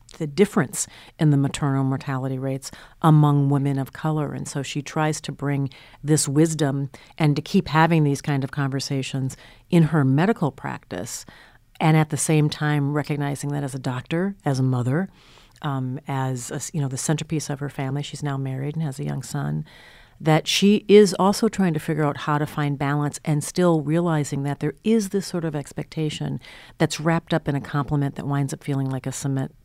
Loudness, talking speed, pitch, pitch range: -23 LUFS, 195 wpm, 145 Hz, 140-160 Hz